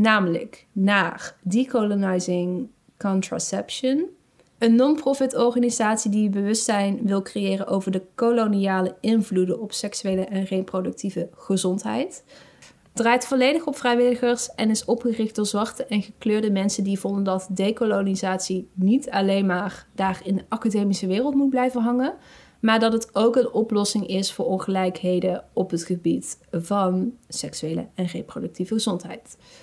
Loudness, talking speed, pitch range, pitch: -23 LUFS, 130 wpm, 190-235 Hz, 205 Hz